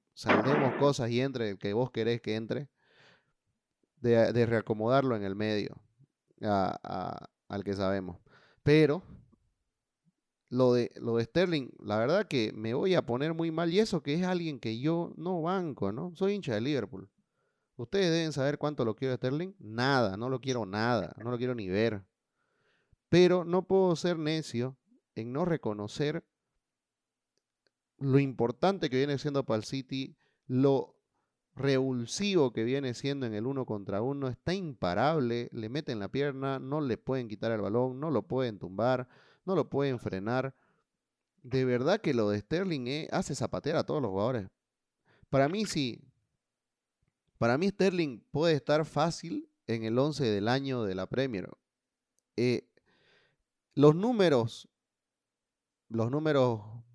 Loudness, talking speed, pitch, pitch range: -31 LUFS, 155 wpm, 130 Hz, 115-155 Hz